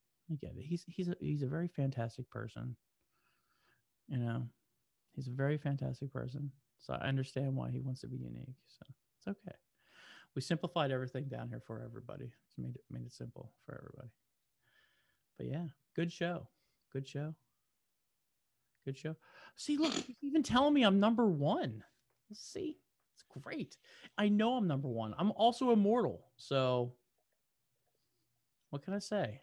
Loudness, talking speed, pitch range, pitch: -37 LUFS, 160 wpm, 125-180 Hz, 135 Hz